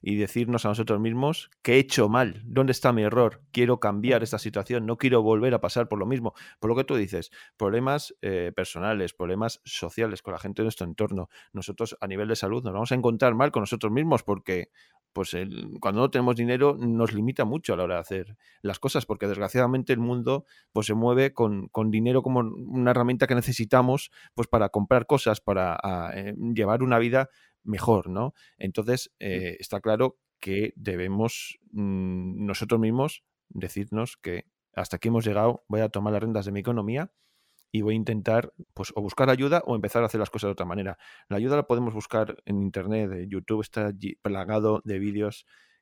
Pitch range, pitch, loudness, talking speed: 100-125 Hz, 110 Hz, -26 LUFS, 200 wpm